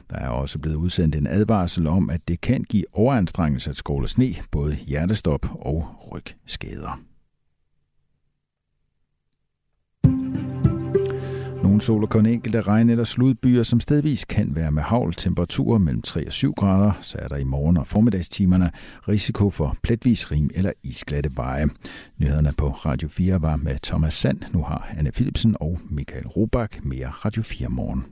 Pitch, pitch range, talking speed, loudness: 90 Hz, 75-110 Hz, 155 wpm, -22 LUFS